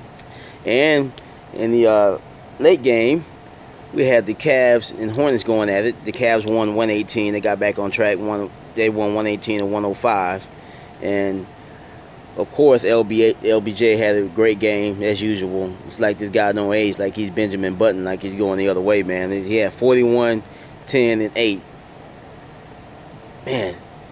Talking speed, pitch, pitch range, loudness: 160 wpm, 105 Hz, 100-115 Hz, -18 LUFS